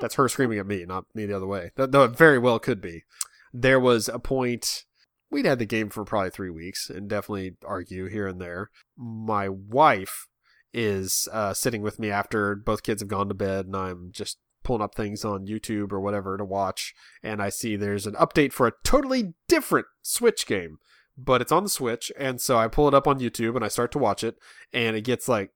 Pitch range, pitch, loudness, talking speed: 100-125 Hz, 110 Hz, -25 LUFS, 225 wpm